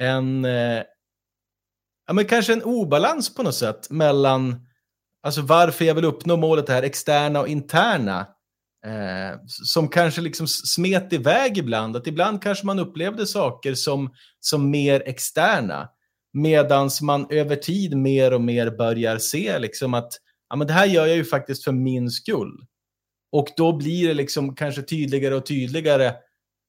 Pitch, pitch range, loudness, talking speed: 140 Hz, 120-165 Hz, -21 LUFS, 155 wpm